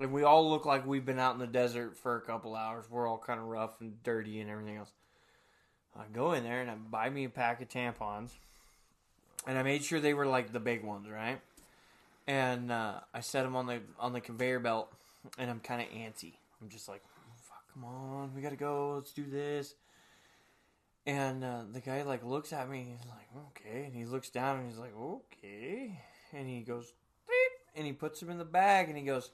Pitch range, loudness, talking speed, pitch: 115-140 Hz, -36 LUFS, 230 wpm, 125 Hz